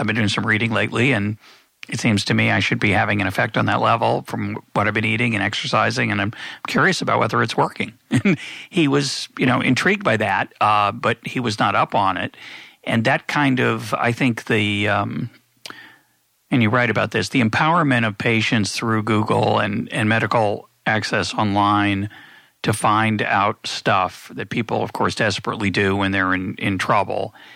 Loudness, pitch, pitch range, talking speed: -19 LUFS, 110 Hz, 105-120 Hz, 190 wpm